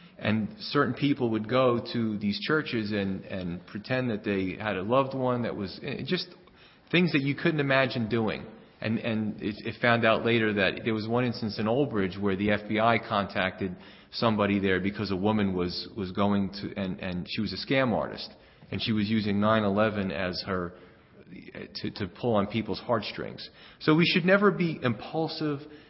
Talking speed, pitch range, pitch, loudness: 185 wpm, 100-130 Hz, 110 Hz, -28 LUFS